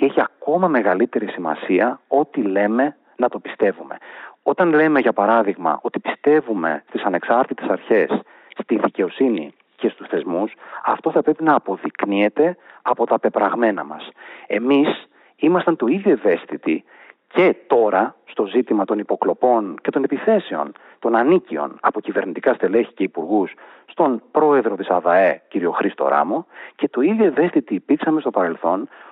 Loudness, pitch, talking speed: -19 LUFS, 150 Hz, 140 wpm